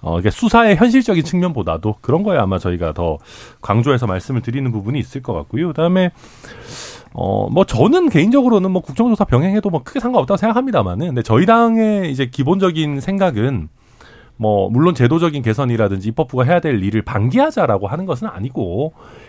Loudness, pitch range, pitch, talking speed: -16 LUFS, 115-190 Hz, 140 Hz, 410 characters per minute